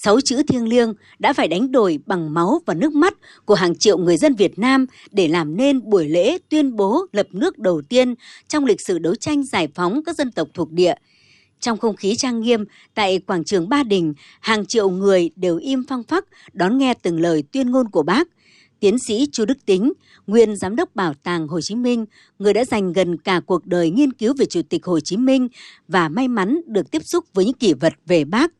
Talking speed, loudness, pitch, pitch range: 225 wpm, -19 LUFS, 225 Hz, 185-270 Hz